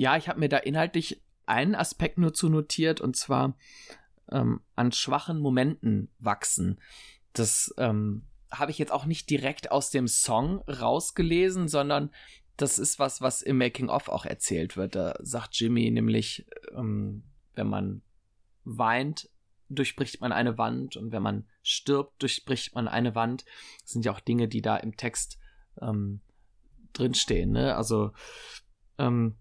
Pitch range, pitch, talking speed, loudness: 110-140 Hz, 120 Hz, 150 wpm, -28 LUFS